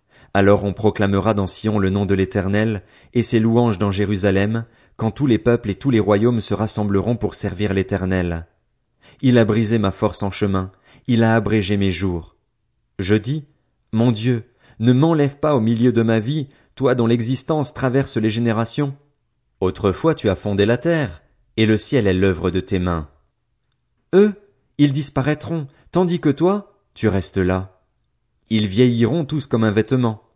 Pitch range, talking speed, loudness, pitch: 100-130 Hz, 170 wpm, -19 LUFS, 115 Hz